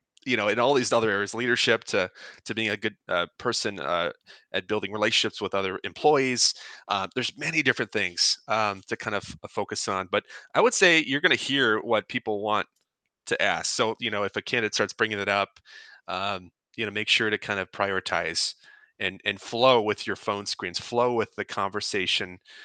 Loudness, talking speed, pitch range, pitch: -25 LUFS, 200 wpm, 100-110 Hz, 105 Hz